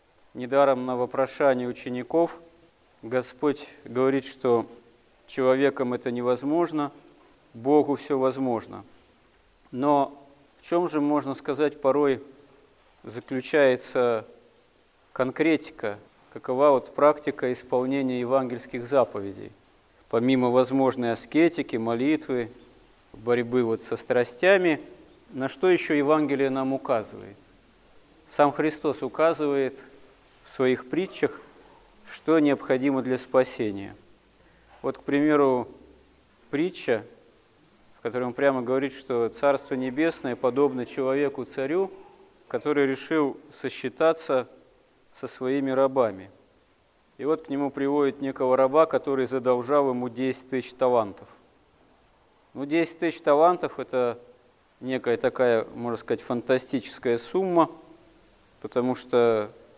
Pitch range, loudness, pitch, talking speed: 125-145 Hz, -25 LUFS, 135 Hz, 100 wpm